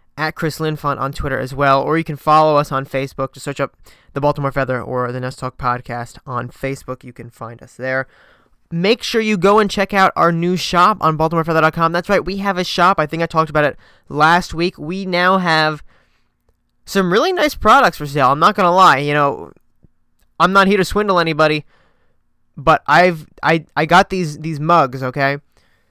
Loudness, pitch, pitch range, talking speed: -16 LUFS, 155 Hz, 135-175 Hz, 205 wpm